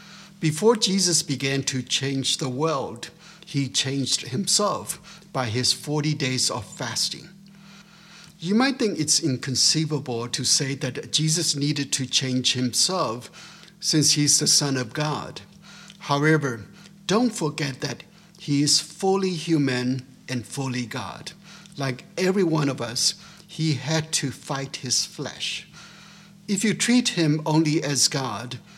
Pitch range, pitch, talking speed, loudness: 135-190 Hz, 155 Hz, 135 wpm, -23 LUFS